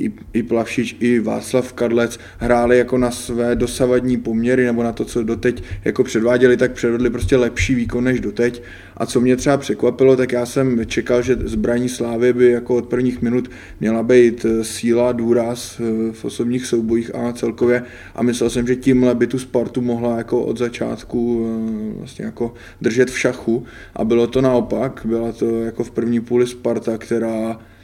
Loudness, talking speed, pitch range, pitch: -18 LUFS, 170 wpm, 115-125 Hz, 120 Hz